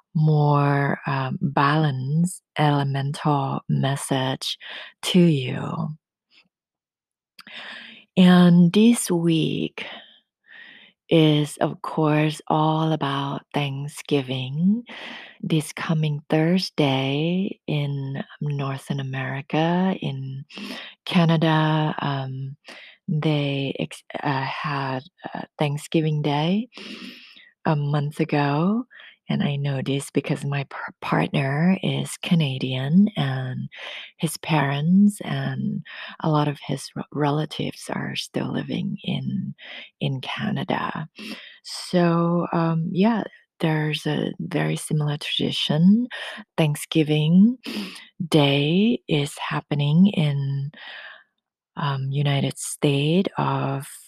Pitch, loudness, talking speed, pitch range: 155 Hz, -23 LUFS, 85 wpm, 140-175 Hz